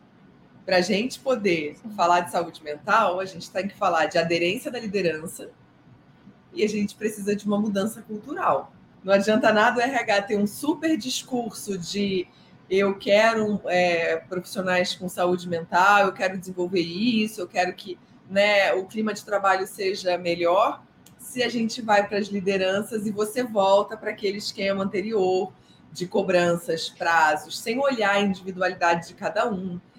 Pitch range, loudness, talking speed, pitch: 180-215 Hz, -24 LUFS, 160 wpm, 195 Hz